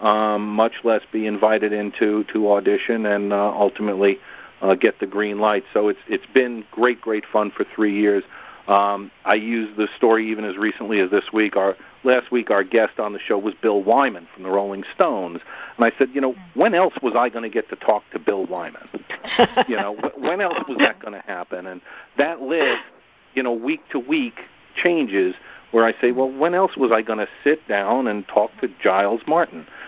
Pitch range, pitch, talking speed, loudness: 105-130 Hz, 110 Hz, 210 wpm, -20 LUFS